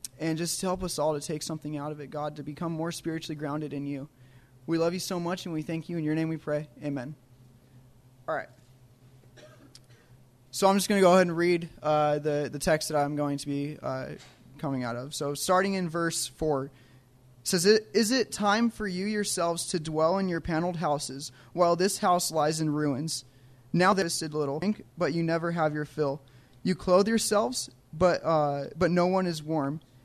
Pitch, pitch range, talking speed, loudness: 155 Hz, 135-175 Hz, 215 wpm, -28 LUFS